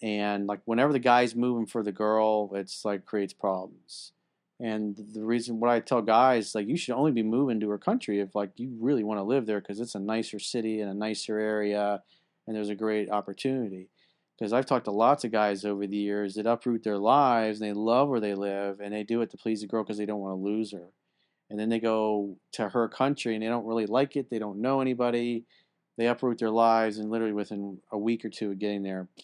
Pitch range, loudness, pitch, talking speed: 105-115 Hz, -28 LUFS, 110 Hz, 240 wpm